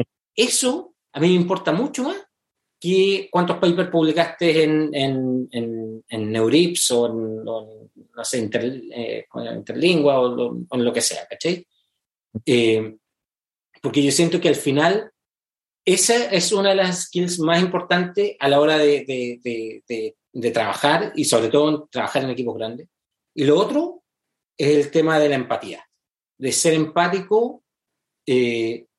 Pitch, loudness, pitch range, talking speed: 150 Hz, -20 LUFS, 120-180 Hz, 160 wpm